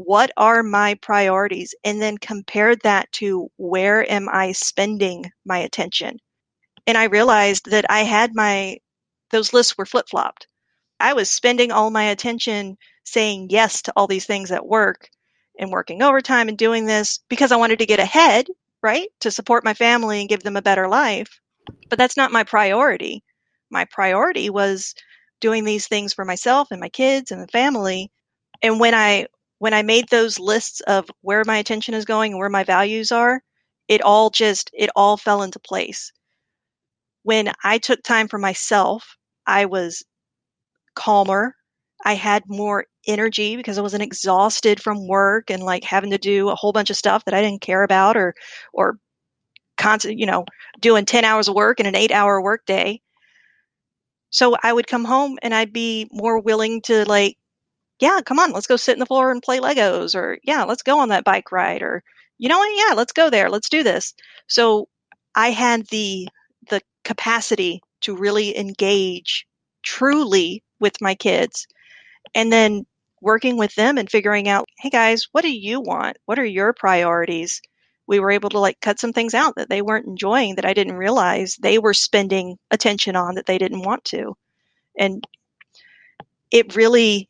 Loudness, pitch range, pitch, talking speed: -18 LUFS, 200-235 Hz, 215 Hz, 180 wpm